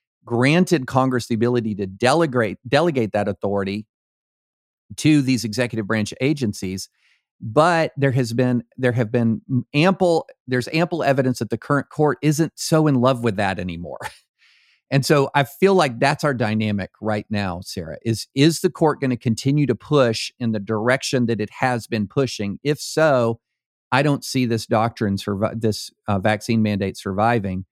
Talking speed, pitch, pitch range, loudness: 165 wpm, 120 Hz, 105-140 Hz, -20 LUFS